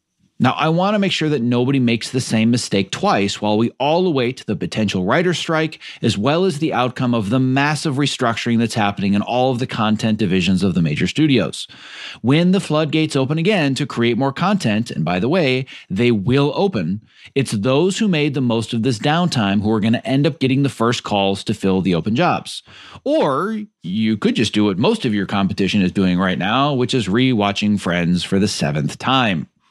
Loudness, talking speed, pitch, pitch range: -18 LUFS, 210 wpm, 125 Hz, 105-150 Hz